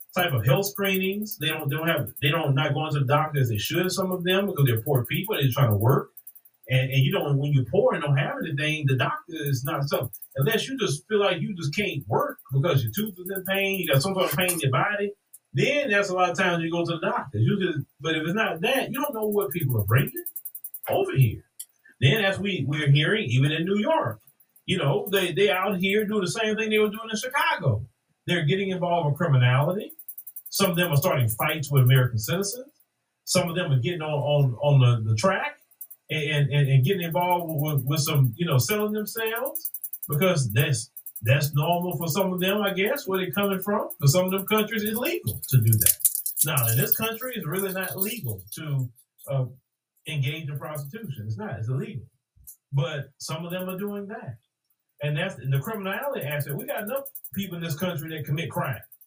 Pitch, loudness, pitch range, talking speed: 155 Hz, -25 LUFS, 135-195 Hz, 225 wpm